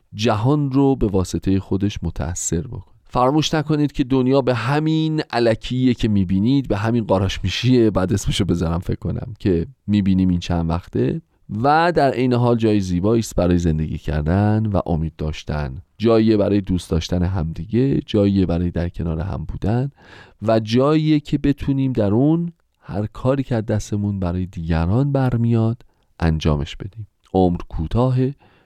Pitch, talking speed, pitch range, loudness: 105 Hz, 150 wpm, 90-125 Hz, -20 LUFS